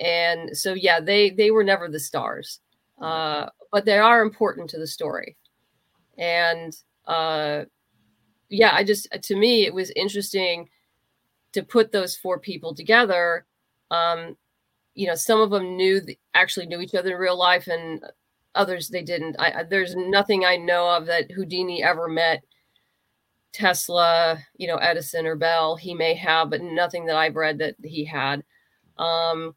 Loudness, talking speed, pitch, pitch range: -22 LUFS, 165 wpm, 170 Hz, 160-190 Hz